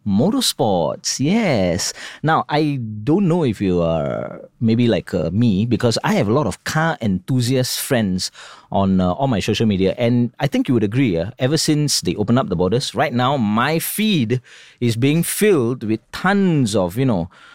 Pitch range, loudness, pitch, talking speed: 105-145 Hz, -18 LUFS, 120 Hz, 185 wpm